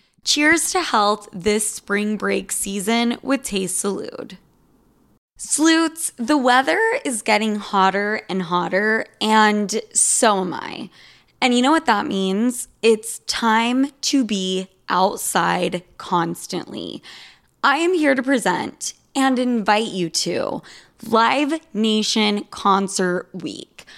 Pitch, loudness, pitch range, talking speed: 220 Hz, -19 LUFS, 200-265 Hz, 120 wpm